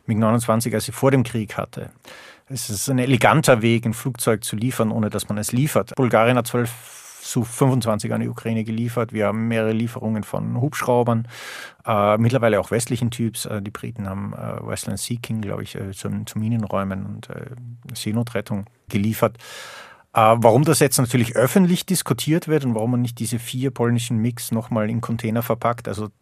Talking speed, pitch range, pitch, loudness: 185 wpm, 110-125 Hz, 115 Hz, -21 LUFS